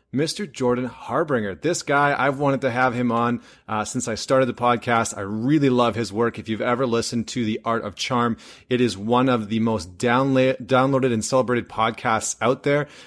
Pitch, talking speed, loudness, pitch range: 120 Hz, 200 wpm, -22 LUFS, 115-130 Hz